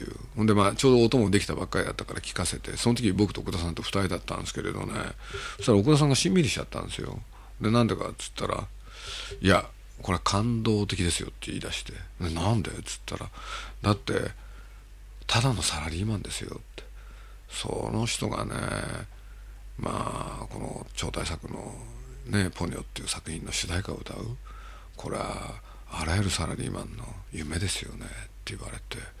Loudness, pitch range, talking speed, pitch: -29 LUFS, 95-115 Hz, 370 characters per minute, 105 Hz